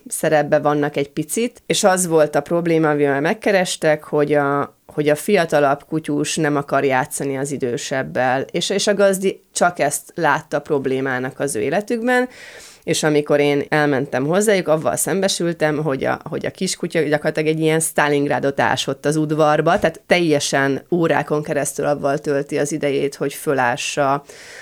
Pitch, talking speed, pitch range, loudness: 150 Hz, 150 wpm, 145-165 Hz, -18 LUFS